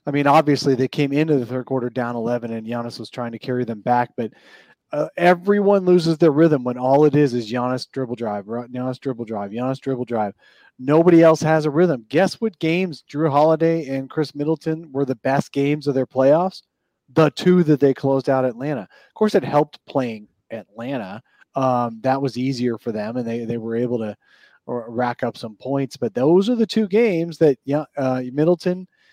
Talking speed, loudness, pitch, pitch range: 200 wpm, -20 LUFS, 135 Hz, 125-160 Hz